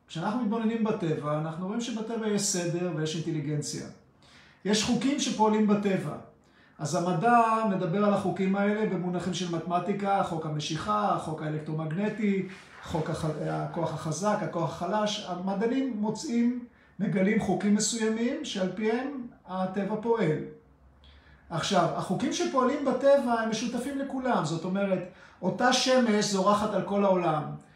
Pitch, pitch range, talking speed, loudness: 195 Hz, 170-225 Hz, 125 wpm, -28 LUFS